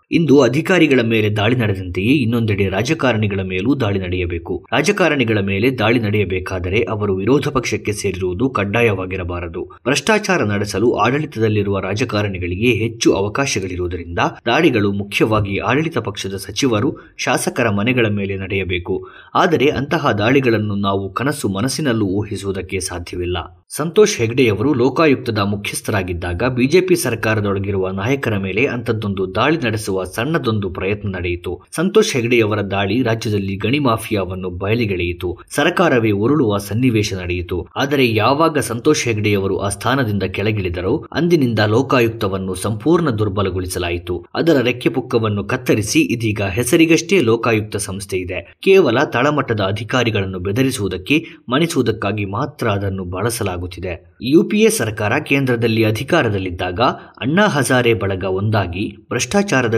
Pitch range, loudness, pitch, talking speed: 95-130 Hz, -17 LUFS, 110 Hz, 105 wpm